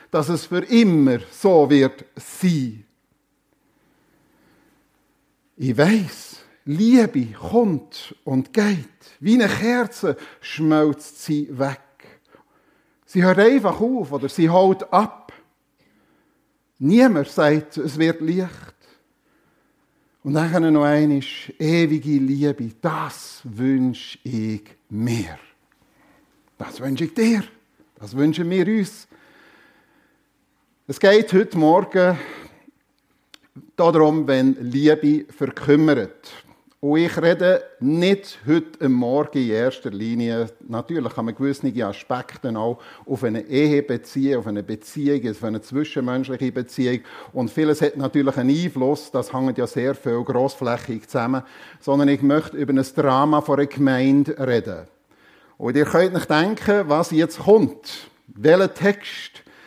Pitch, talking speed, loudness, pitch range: 150 Hz, 120 wpm, -20 LUFS, 130-180 Hz